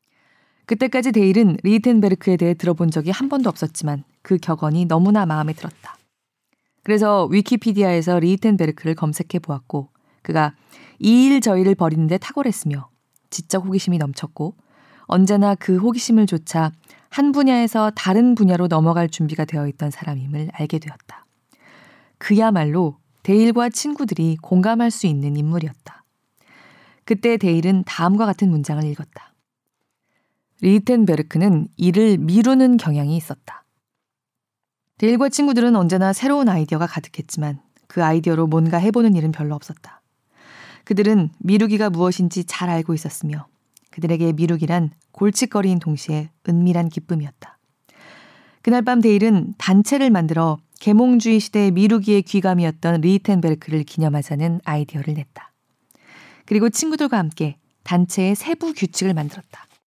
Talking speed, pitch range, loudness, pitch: 335 characters per minute, 160-215 Hz, -18 LUFS, 180 Hz